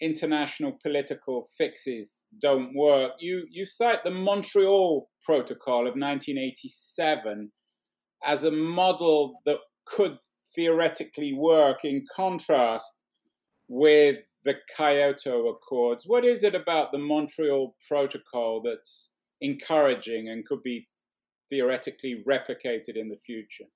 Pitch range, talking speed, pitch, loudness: 140-190 Hz, 110 wpm, 150 Hz, -26 LUFS